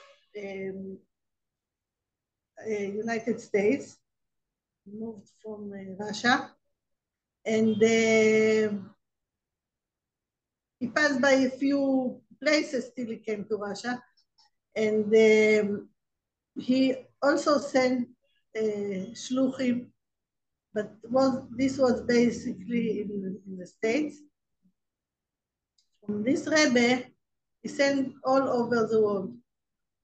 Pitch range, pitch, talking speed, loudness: 210-265 Hz, 230 Hz, 95 wpm, -26 LUFS